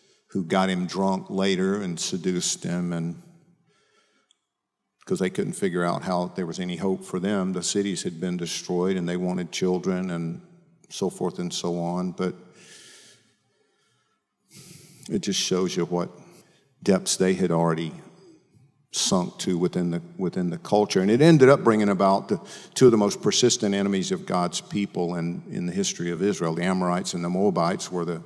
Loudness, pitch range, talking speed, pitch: -24 LUFS, 90-140 Hz, 175 wpm, 95 Hz